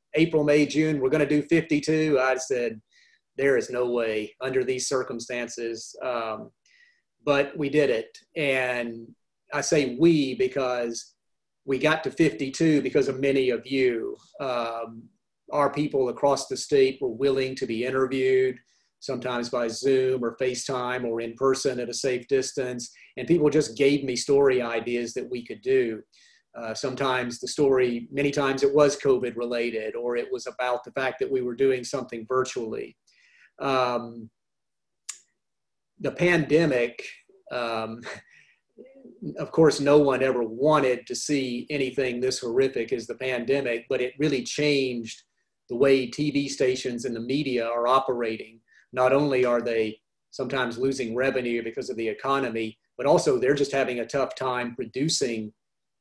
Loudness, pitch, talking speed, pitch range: -25 LUFS, 130 Hz, 155 wpm, 120-145 Hz